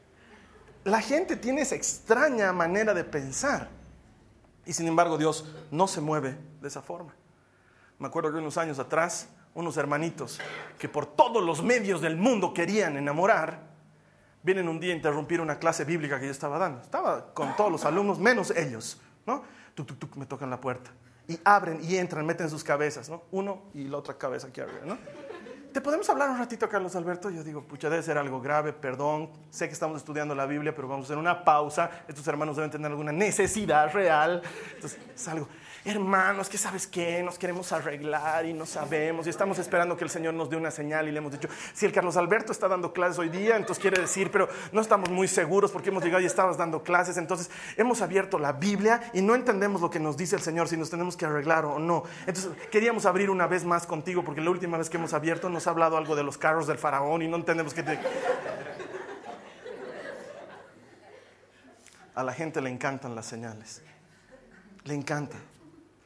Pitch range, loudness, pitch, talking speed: 150-185 Hz, -28 LUFS, 165 Hz, 200 wpm